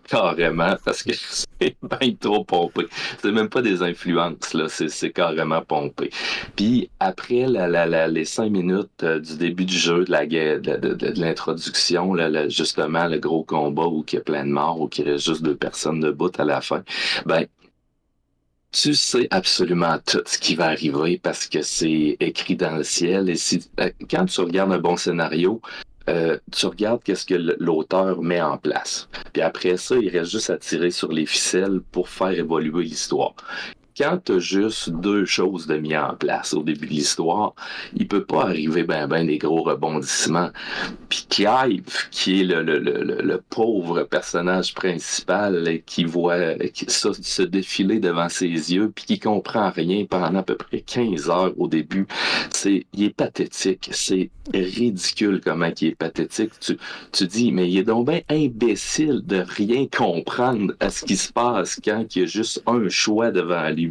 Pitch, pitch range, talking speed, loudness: 90 Hz, 80-95 Hz, 185 wpm, -22 LUFS